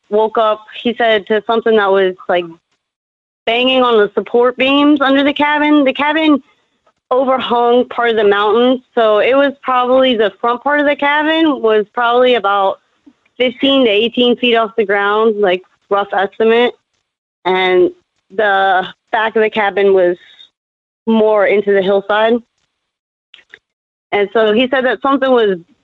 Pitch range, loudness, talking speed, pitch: 205-255 Hz, -13 LUFS, 150 wpm, 230 Hz